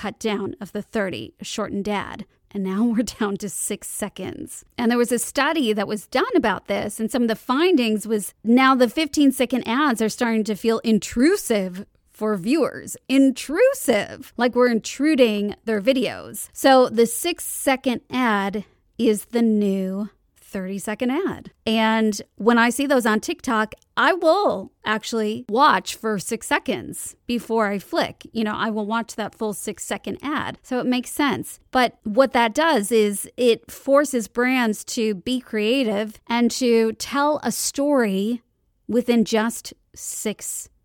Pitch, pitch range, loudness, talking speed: 230 Hz, 215-255 Hz, -21 LUFS, 160 wpm